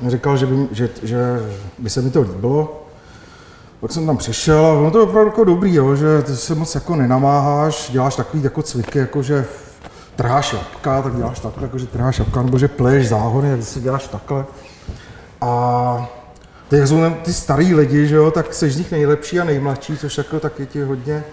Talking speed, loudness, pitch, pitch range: 195 wpm, -17 LUFS, 140 Hz, 120-150 Hz